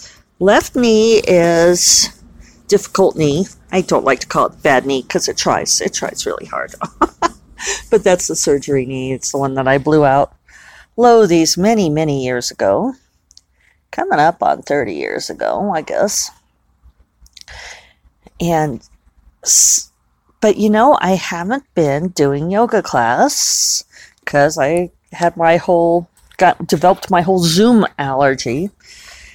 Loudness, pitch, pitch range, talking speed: -14 LUFS, 170 Hz, 135-190 Hz, 135 wpm